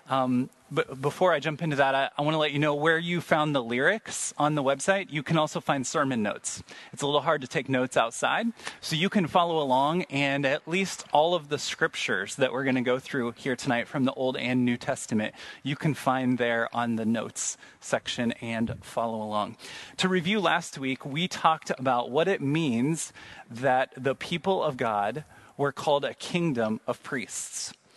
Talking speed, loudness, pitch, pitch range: 200 wpm, -27 LUFS, 140 Hz, 125-160 Hz